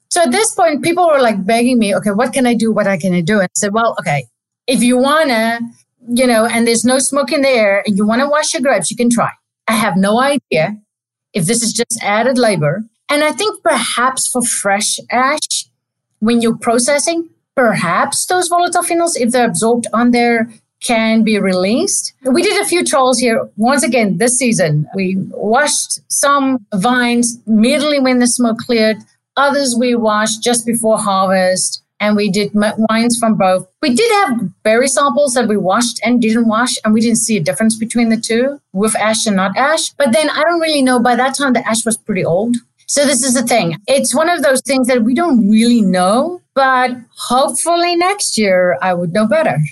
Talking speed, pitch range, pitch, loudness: 205 wpm, 210-270 Hz, 235 Hz, -13 LUFS